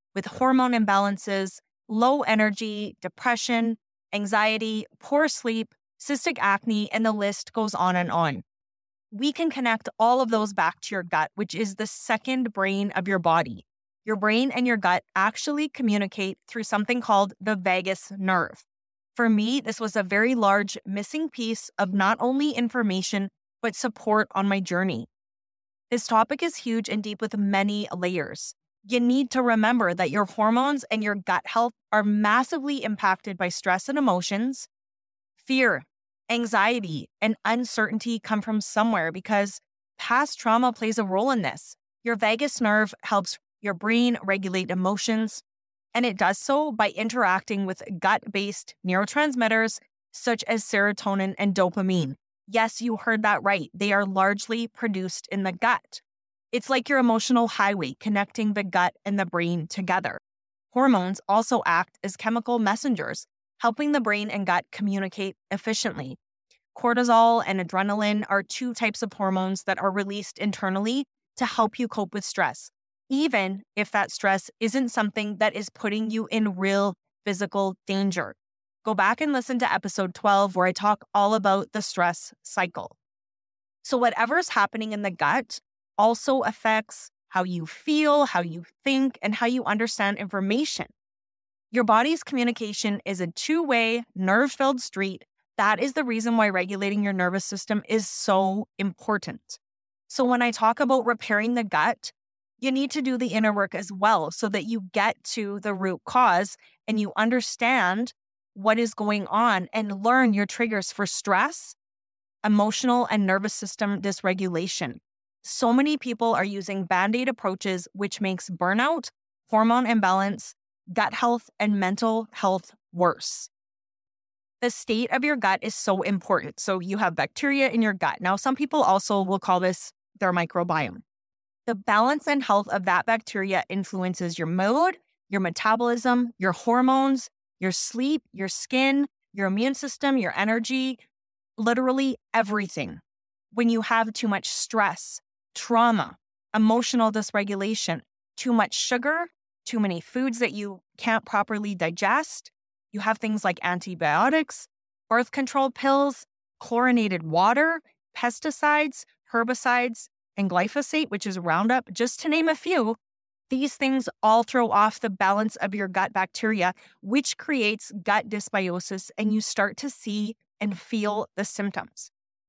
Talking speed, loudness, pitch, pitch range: 150 wpm, -25 LUFS, 215 Hz, 195-240 Hz